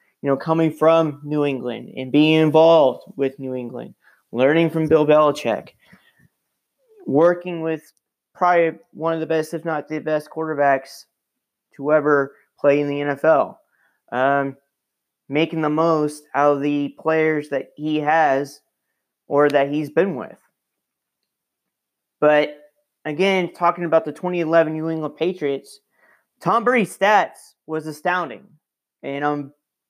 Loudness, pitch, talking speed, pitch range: -20 LUFS, 155 Hz, 130 wpm, 145-165 Hz